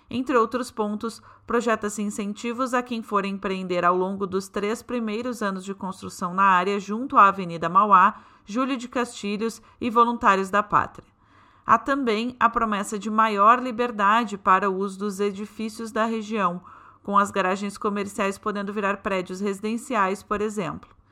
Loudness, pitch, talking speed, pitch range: -23 LUFS, 210 Hz, 155 wpm, 200-230 Hz